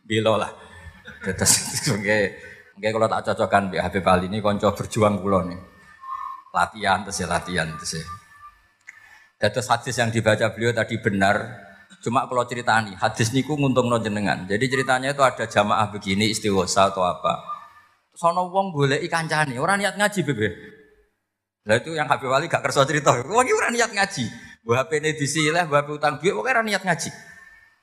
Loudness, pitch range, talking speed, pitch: -22 LUFS, 105-165 Hz, 155 wpm, 120 Hz